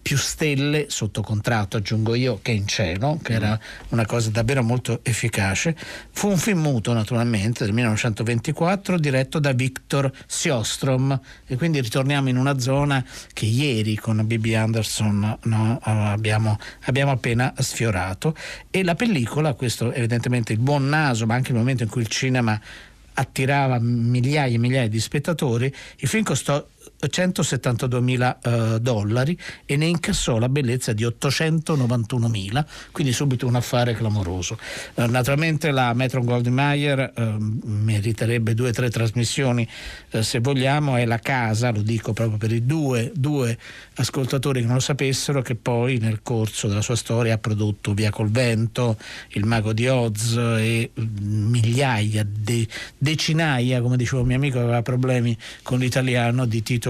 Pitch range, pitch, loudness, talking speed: 115-135 Hz, 125 Hz, -22 LUFS, 150 wpm